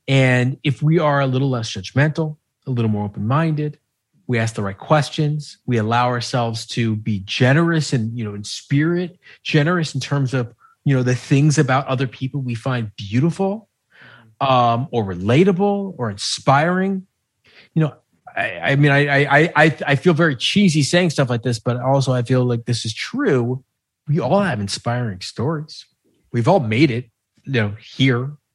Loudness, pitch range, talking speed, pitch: -19 LUFS, 120-155 Hz, 175 wpm, 135 Hz